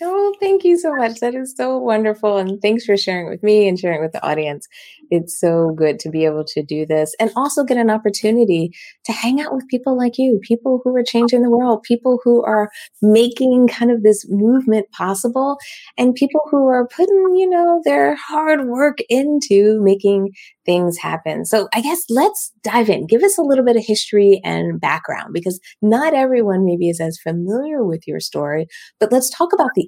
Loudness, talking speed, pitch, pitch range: -16 LUFS, 200 wpm, 230 Hz, 195-260 Hz